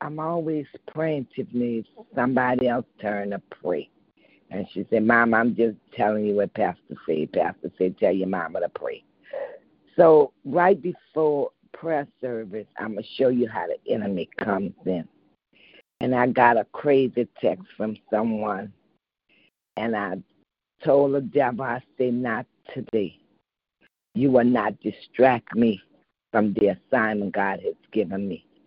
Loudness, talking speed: -24 LUFS, 145 wpm